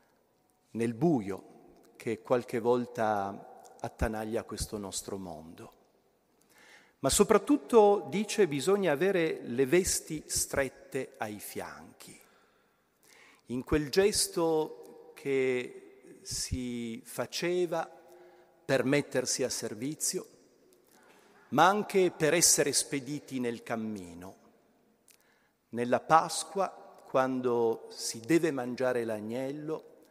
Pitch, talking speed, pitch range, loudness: 140 Hz, 85 wpm, 120-175 Hz, -30 LUFS